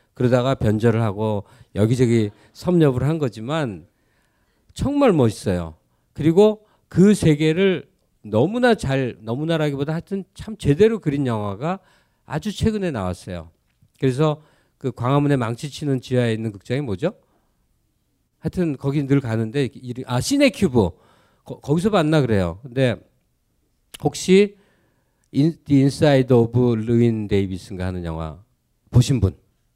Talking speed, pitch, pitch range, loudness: 270 characters per minute, 130 Hz, 110-155 Hz, -20 LUFS